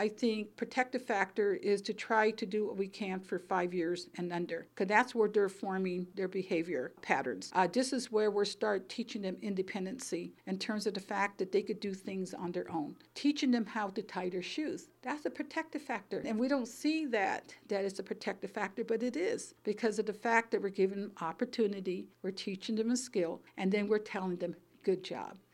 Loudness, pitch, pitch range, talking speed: -35 LUFS, 205 Hz, 190-230 Hz, 215 wpm